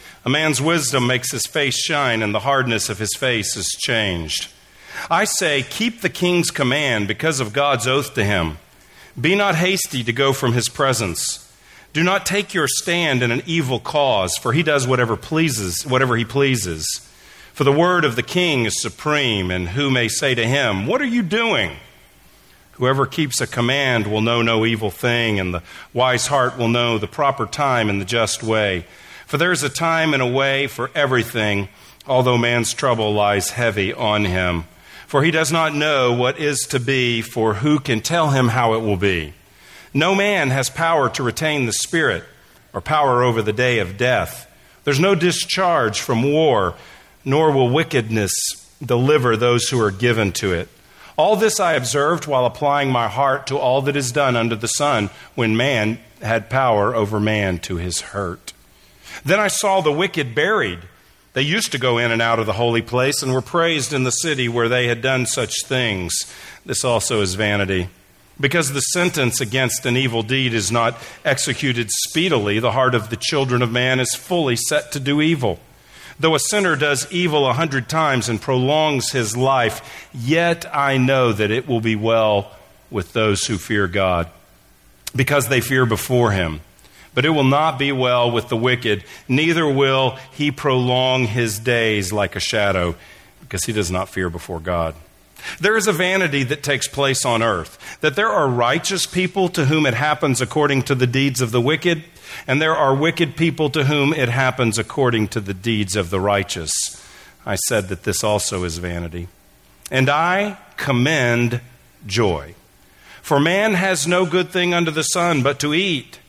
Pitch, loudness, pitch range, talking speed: 125 Hz, -18 LUFS, 110-150 Hz, 185 wpm